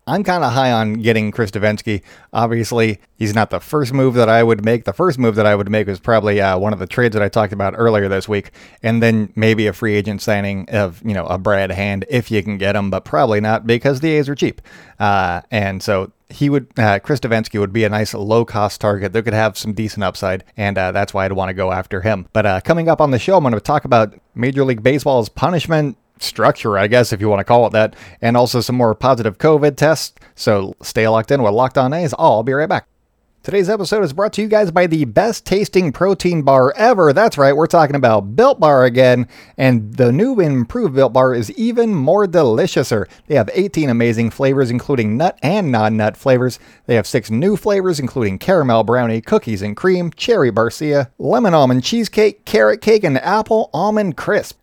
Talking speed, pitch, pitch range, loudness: 225 wpm, 115 Hz, 105-145 Hz, -15 LUFS